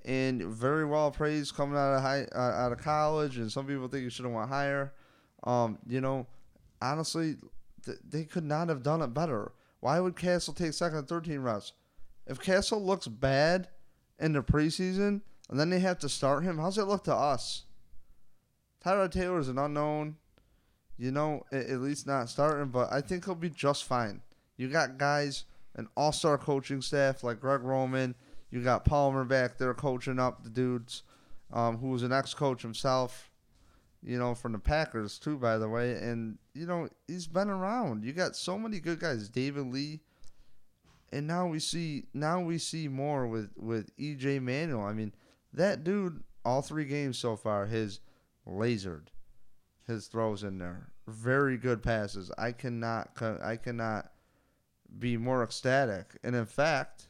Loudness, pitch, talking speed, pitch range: -32 LUFS, 135 Hz, 175 wpm, 120-155 Hz